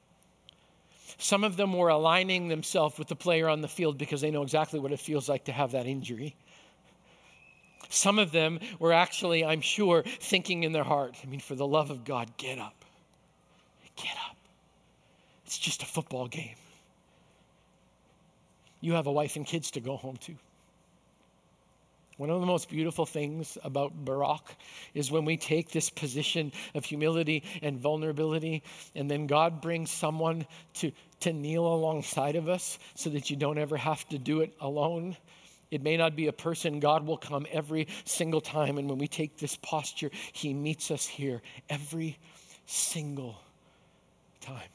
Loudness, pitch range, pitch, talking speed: -31 LUFS, 145-165 Hz, 155 Hz, 170 wpm